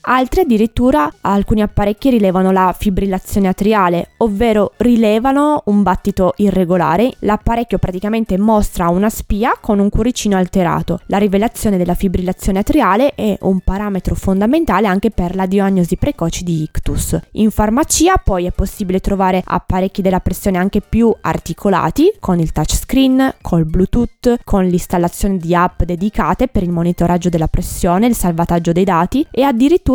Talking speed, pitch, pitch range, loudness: 140 wpm, 200 Hz, 180-225 Hz, -15 LUFS